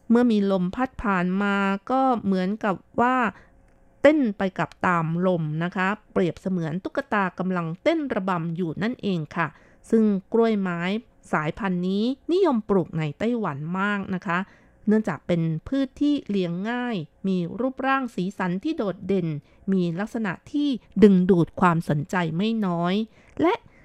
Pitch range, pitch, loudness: 180-230 Hz, 195 Hz, -24 LUFS